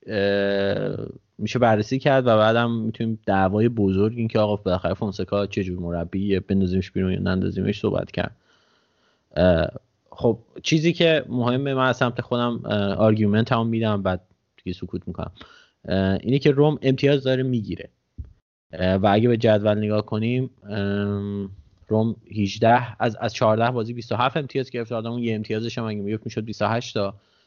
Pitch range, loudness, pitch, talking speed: 100-120 Hz, -22 LUFS, 110 Hz, 145 wpm